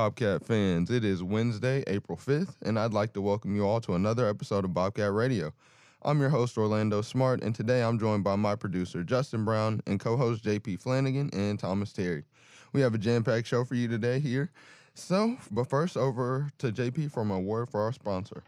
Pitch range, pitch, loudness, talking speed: 105-130 Hz, 115 Hz, -29 LUFS, 200 wpm